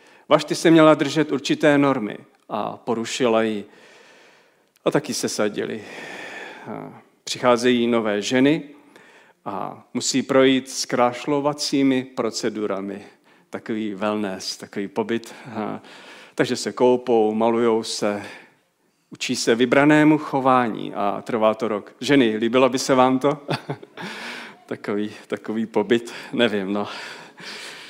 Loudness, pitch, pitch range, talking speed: -21 LUFS, 125 Hz, 110-145 Hz, 110 wpm